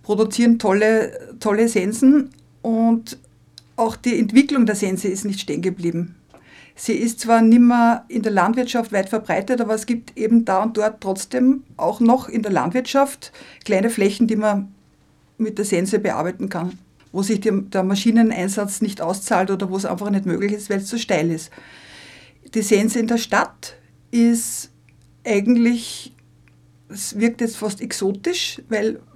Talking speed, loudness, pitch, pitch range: 160 wpm, -19 LUFS, 220 Hz, 195-235 Hz